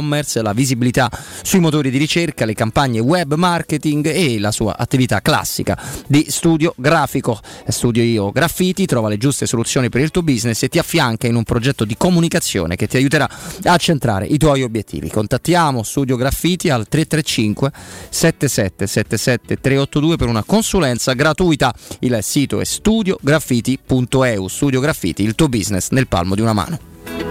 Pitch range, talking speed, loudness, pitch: 115-155 Hz, 150 wpm, -16 LUFS, 130 Hz